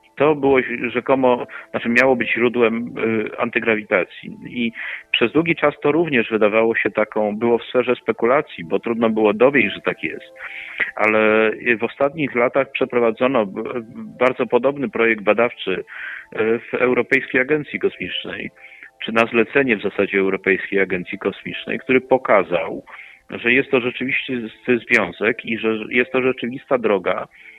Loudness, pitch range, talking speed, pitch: -19 LUFS, 110-130 Hz, 135 wpm, 120 Hz